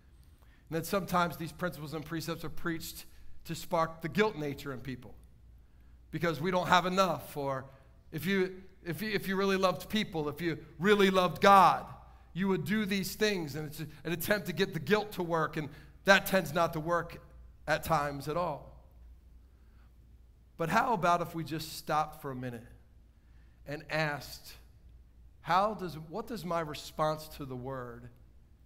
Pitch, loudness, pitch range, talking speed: 160 Hz, -31 LUFS, 135-180 Hz, 175 wpm